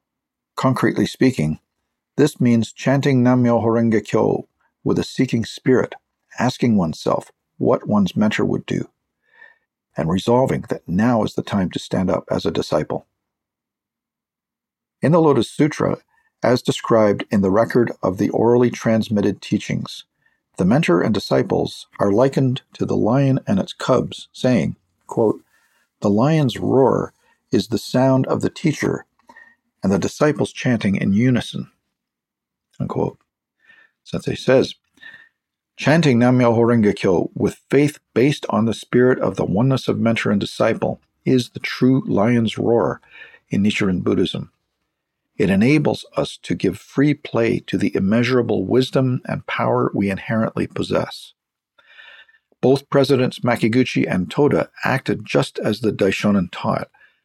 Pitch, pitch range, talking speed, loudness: 125 Hz, 115-140 Hz, 135 wpm, -19 LUFS